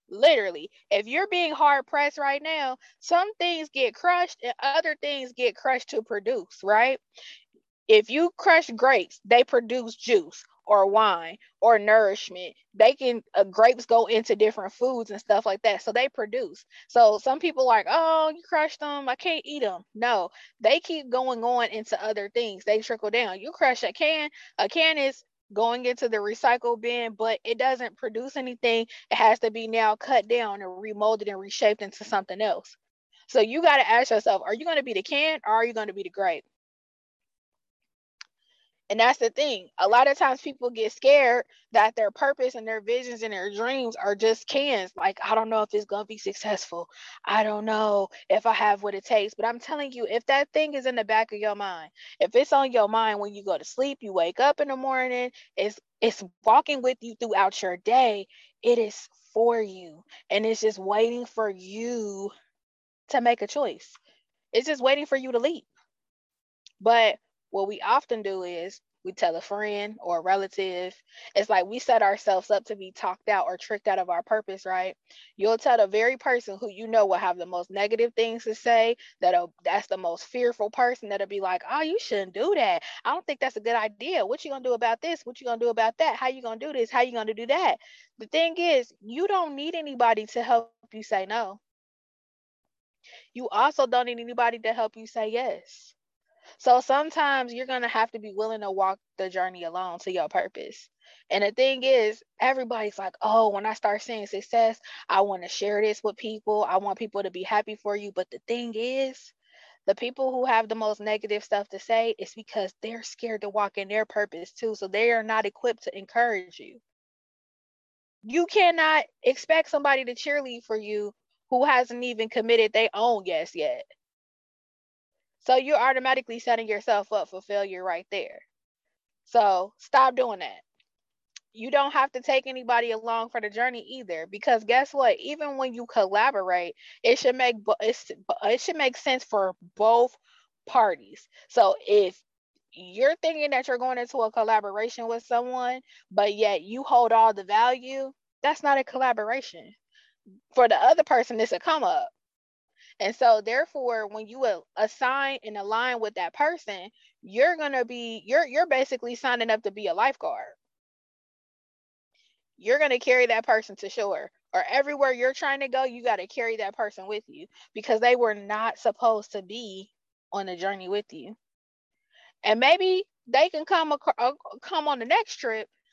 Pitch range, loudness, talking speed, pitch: 210-275 Hz, -25 LUFS, 195 wpm, 235 Hz